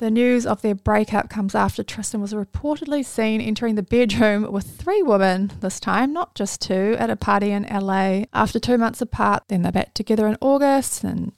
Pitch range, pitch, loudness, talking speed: 205-245 Hz, 215 Hz, -21 LUFS, 200 wpm